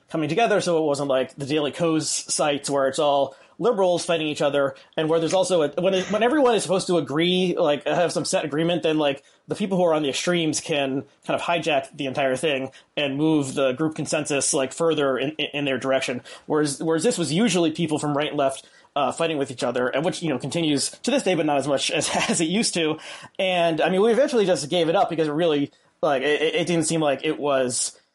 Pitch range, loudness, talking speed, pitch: 140-175 Hz, -23 LUFS, 240 wpm, 155 Hz